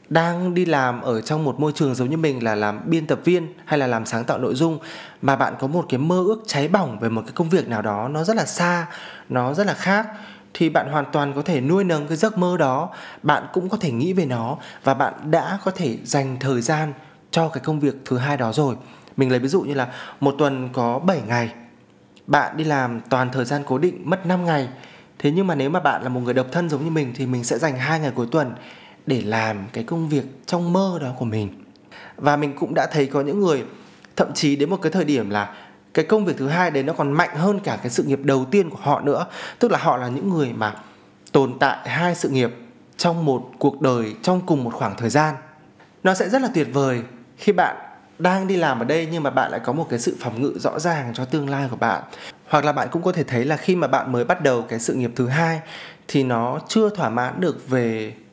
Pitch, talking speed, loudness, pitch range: 145 Hz, 255 wpm, -21 LUFS, 125-170 Hz